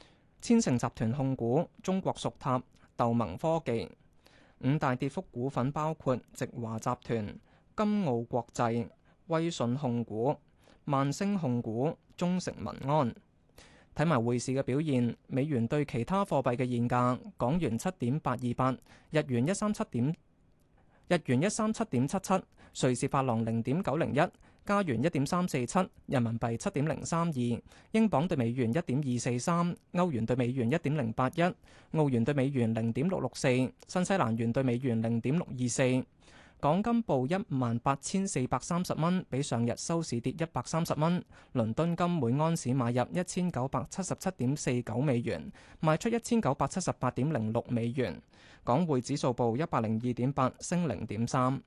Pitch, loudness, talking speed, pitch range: 130 Hz, -31 LUFS, 240 characters per minute, 120-165 Hz